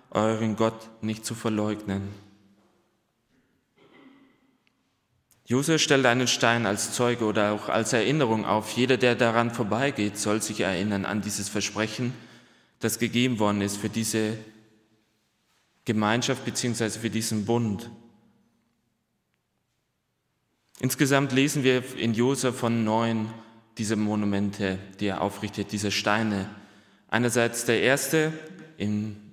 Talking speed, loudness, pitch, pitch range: 115 wpm, -26 LUFS, 110 Hz, 105-120 Hz